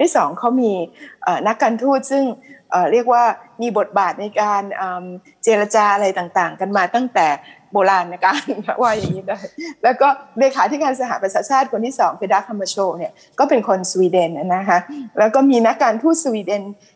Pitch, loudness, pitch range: 215 Hz, -17 LUFS, 190-255 Hz